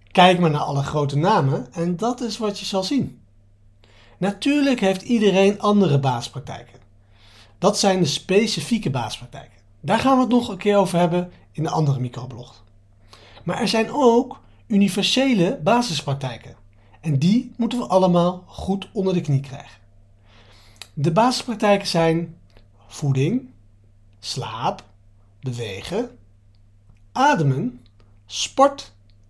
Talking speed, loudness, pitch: 125 wpm, -20 LUFS, 140 Hz